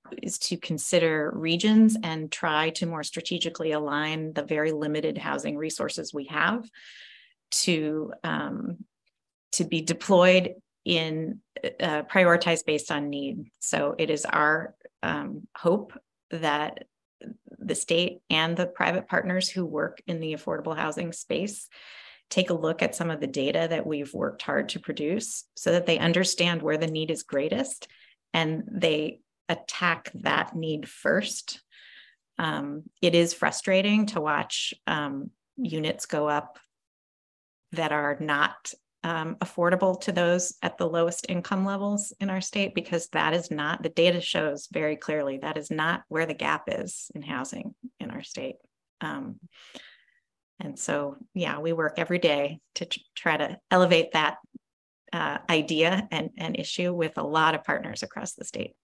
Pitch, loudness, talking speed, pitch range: 170 Hz, -27 LUFS, 155 wpm, 155-185 Hz